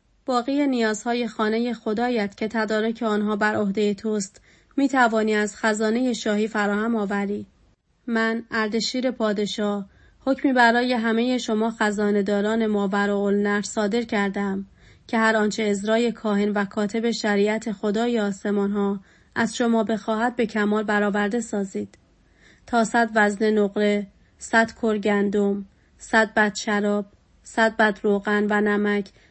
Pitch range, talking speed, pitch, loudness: 205-230 Hz, 125 wpm, 215 Hz, -23 LUFS